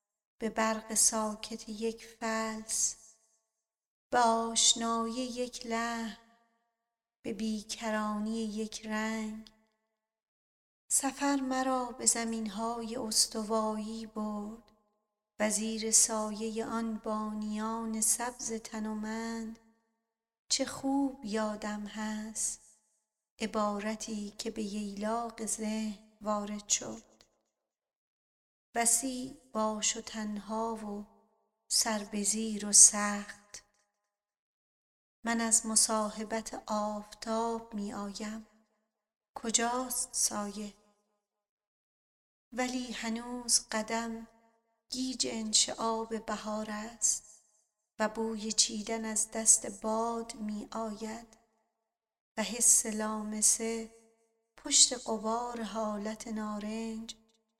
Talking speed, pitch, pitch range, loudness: 80 wpm, 220 Hz, 215-230 Hz, -31 LUFS